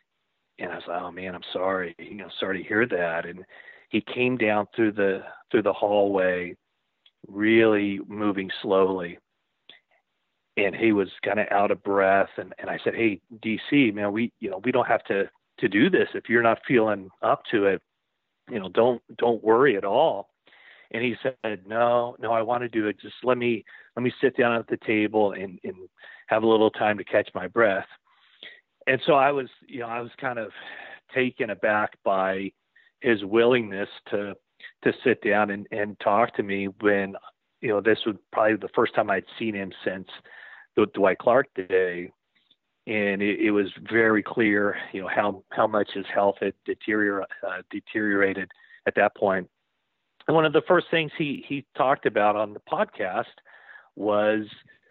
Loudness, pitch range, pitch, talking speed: -25 LUFS, 100-115 Hz, 105 Hz, 185 wpm